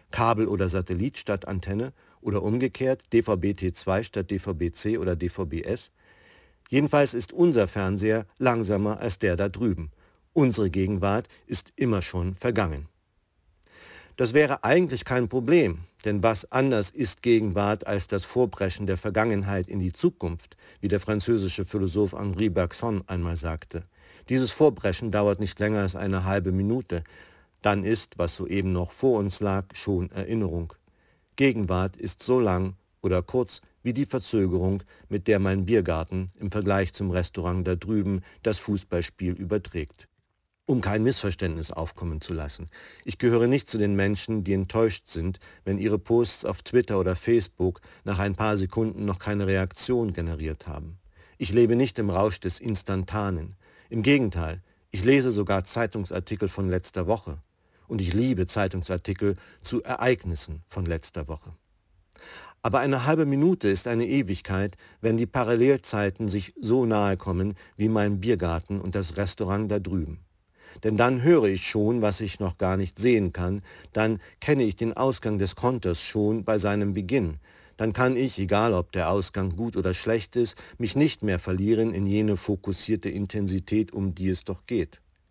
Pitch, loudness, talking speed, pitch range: 100 Hz, -26 LUFS, 155 wpm, 90-115 Hz